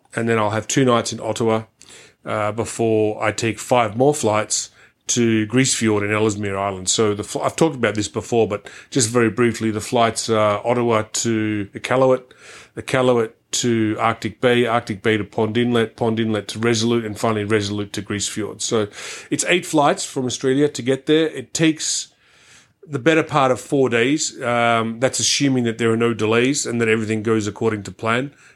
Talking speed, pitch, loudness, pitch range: 185 wpm, 115 Hz, -19 LUFS, 110-125 Hz